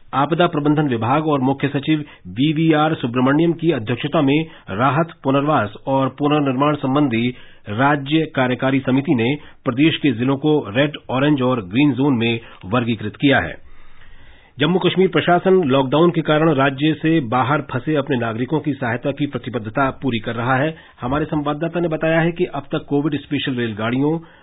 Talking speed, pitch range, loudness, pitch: 155 wpm, 125-155 Hz, -18 LUFS, 140 Hz